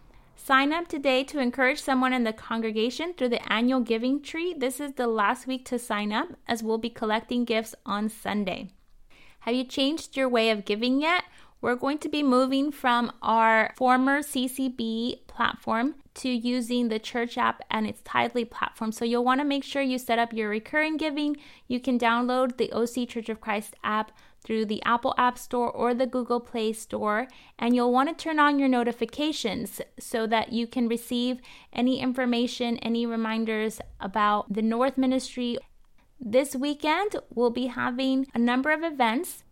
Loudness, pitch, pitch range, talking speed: -26 LUFS, 245 Hz, 230-265 Hz, 180 wpm